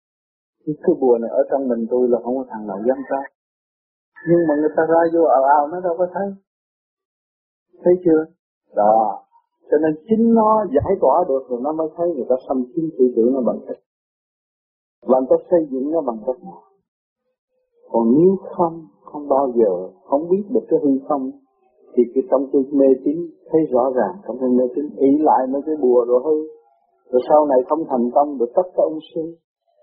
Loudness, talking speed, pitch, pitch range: -18 LUFS, 205 wpm, 155 Hz, 130-175 Hz